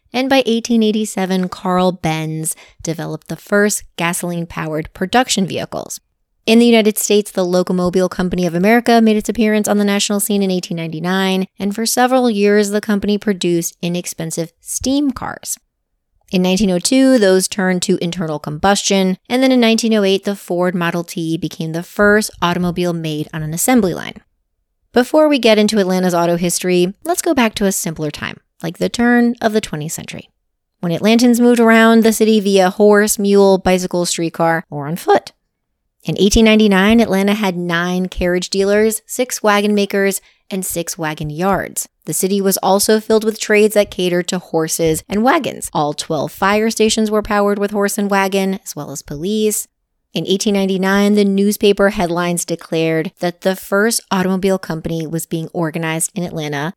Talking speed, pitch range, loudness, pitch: 165 wpm, 175-215 Hz, -15 LUFS, 195 Hz